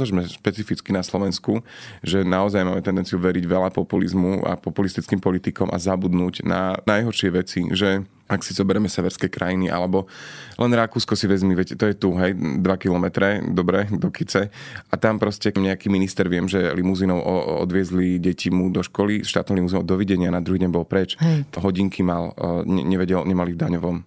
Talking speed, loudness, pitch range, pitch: 170 wpm, -22 LUFS, 90-100 Hz, 95 Hz